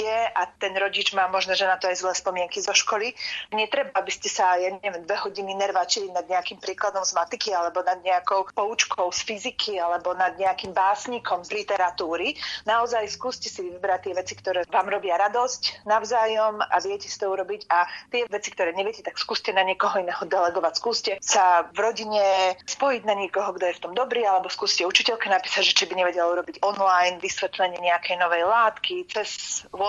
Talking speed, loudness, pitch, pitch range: 185 wpm, -24 LUFS, 195 Hz, 180-215 Hz